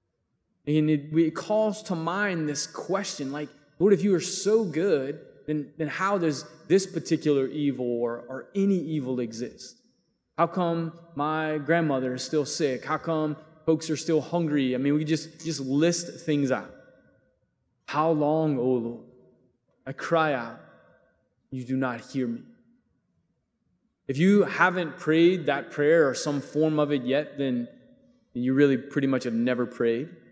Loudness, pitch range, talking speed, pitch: -26 LUFS, 135-170 Hz, 160 wpm, 155 Hz